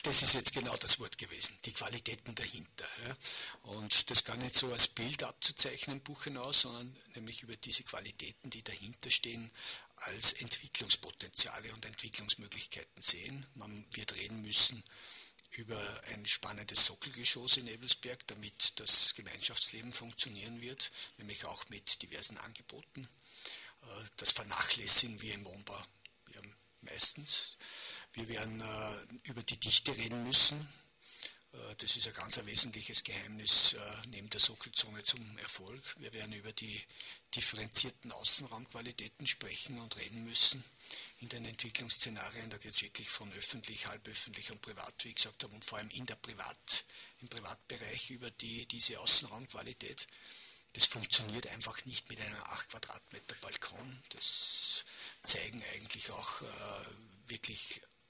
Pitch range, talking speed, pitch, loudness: 105-125 Hz, 140 wpm, 115 Hz, -21 LUFS